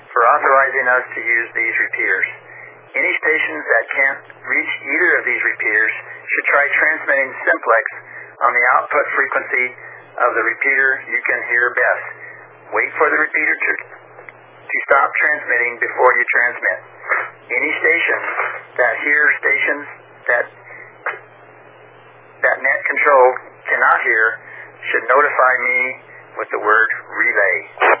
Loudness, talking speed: -15 LUFS, 130 wpm